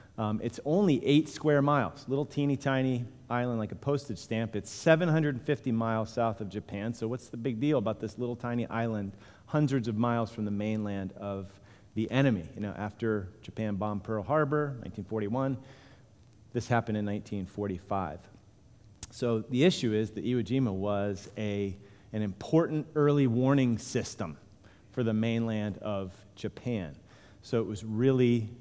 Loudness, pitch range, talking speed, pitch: -31 LUFS, 105-125 Hz, 155 wpm, 110 Hz